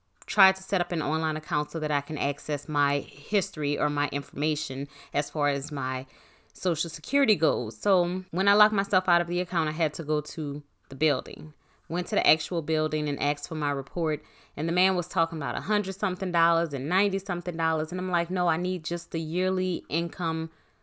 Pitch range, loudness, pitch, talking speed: 145-180 Hz, -27 LUFS, 165 Hz, 215 wpm